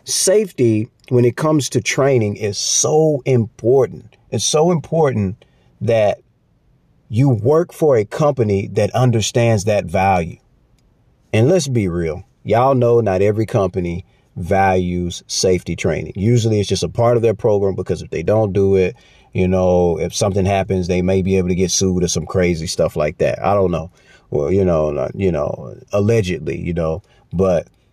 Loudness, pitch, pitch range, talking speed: -17 LUFS, 105 Hz, 95-125 Hz, 170 wpm